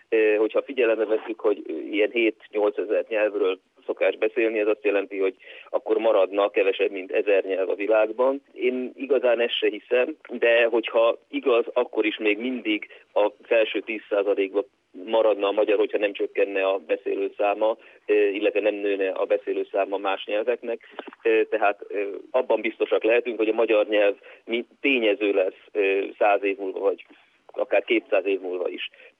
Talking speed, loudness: 145 wpm, -24 LUFS